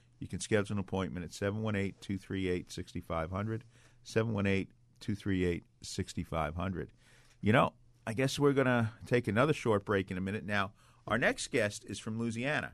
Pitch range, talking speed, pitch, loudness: 95-120 Hz, 135 wpm, 105 Hz, -34 LUFS